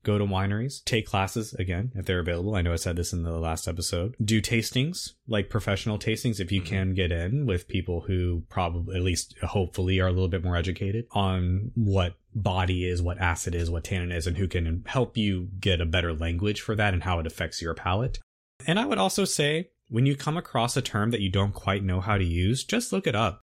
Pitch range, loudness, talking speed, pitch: 90-110 Hz, -27 LUFS, 230 wpm, 95 Hz